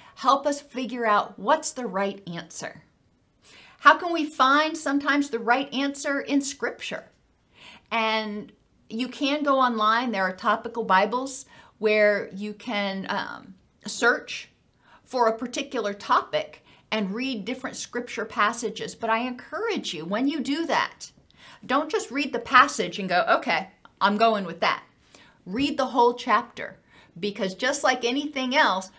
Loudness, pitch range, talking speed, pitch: -25 LUFS, 210-275 Hz, 145 wpm, 240 Hz